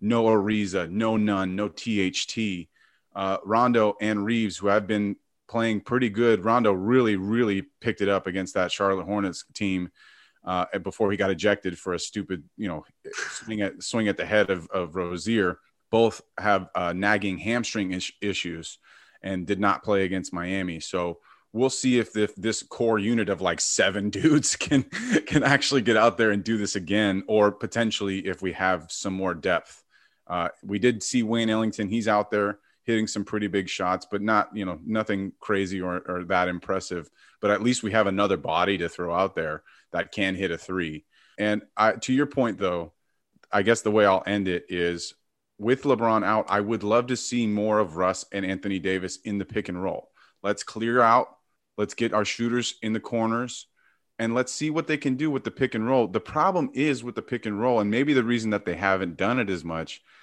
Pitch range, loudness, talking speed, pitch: 95-115 Hz, -25 LUFS, 205 wpm, 105 Hz